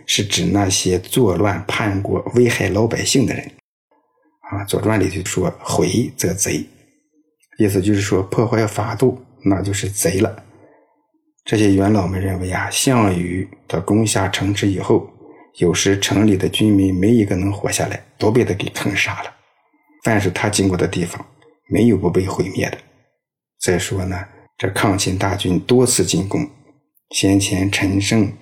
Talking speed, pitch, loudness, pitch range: 230 characters per minute, 100 Hz, -18 LUFS, 95-120 Hz